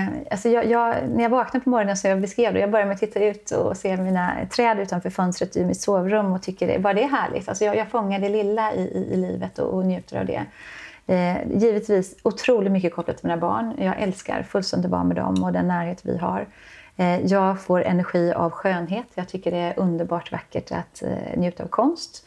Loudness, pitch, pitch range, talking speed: -23 LUFS, 195 Hz, 175-215 Hz, 225 wpm